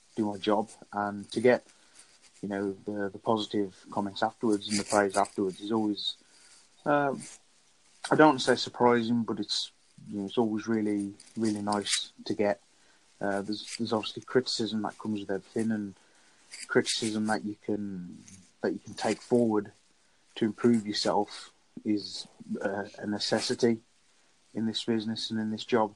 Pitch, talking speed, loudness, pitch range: 105 Hz, 160 wpm, -30 LUFS, 105-115 Hz